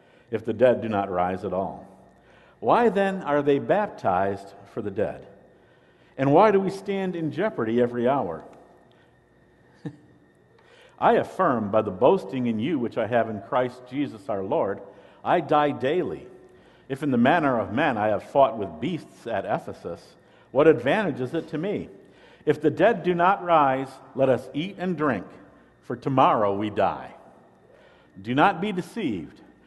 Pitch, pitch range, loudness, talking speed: 135 Hz, 110-170 Hz, -24 LUFS, 165 wpm